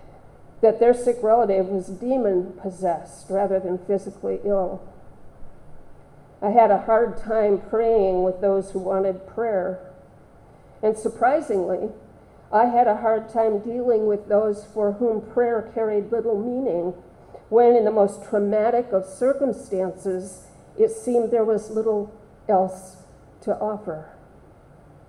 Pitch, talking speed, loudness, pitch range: 210 Hz, 125 wpm, -22 LUFS, 190-225 Hz